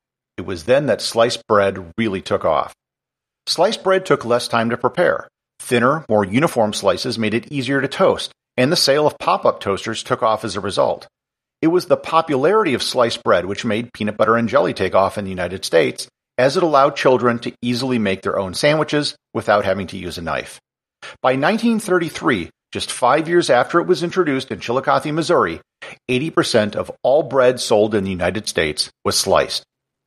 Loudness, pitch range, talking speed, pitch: -18 LUFS, 110-150 Hz, 190 wpm, 125 Hz